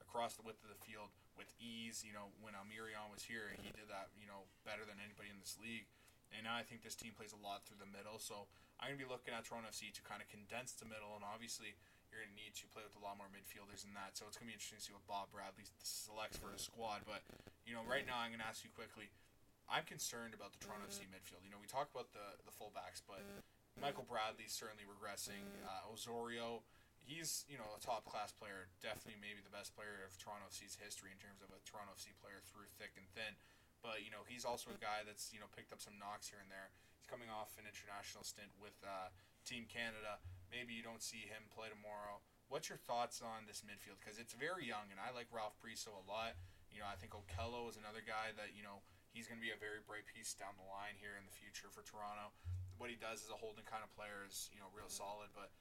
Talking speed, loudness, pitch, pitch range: 255 wpm, -51 LUFS, 105 Hz, 100-110 Hz